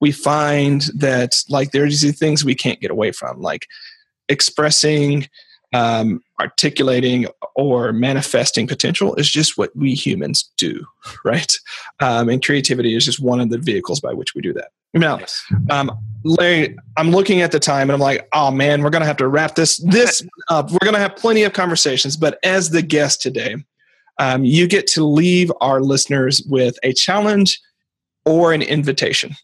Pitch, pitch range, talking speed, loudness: 145 Hz, 135-165 Hz, 175 wpm, -16 LUFS